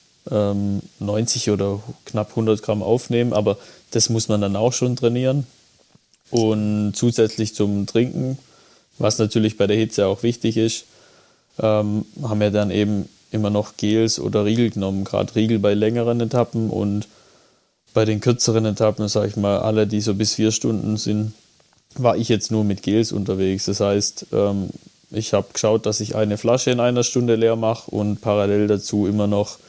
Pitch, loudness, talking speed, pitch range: 110 Hz, -20 LUFS, 165 wpm, 105-115 Hz